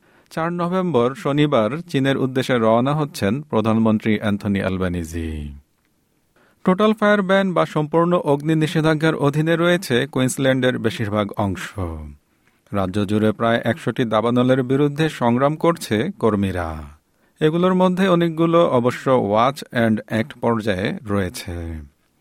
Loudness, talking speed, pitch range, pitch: -19 LUFS, 110 wpm, 105-160 Hz, 125 Hz